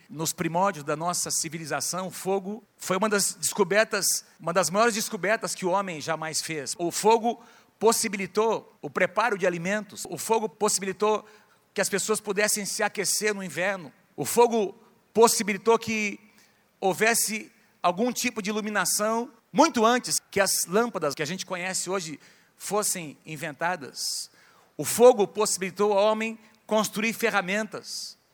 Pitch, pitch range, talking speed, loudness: 205 Hz, 180-220 Hz, 140 wpm, -25 LUFS